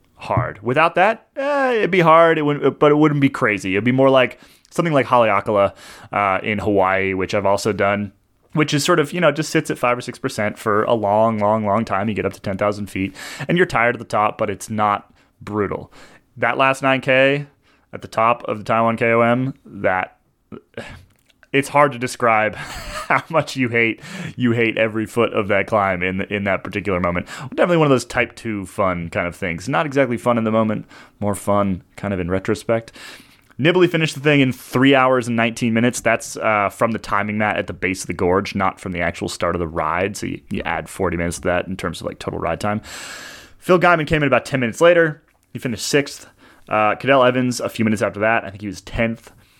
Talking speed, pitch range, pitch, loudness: 225 wpm, 100-135 Hz, 115 Hz, -19 LUFS